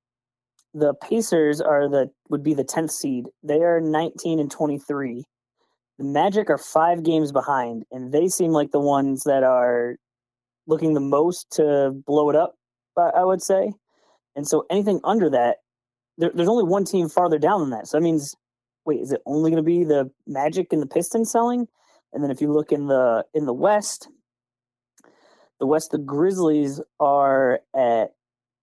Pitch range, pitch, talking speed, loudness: 130-170 Hz, 150 Hz, 175 wpm, -21 LUFS